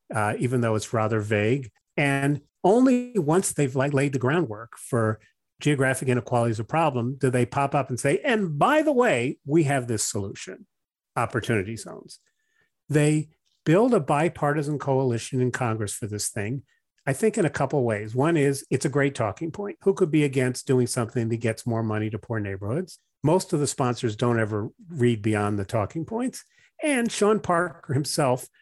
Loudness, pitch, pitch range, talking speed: -25 LUFS, 135 Hz, 115-165 Hz, 180 wpm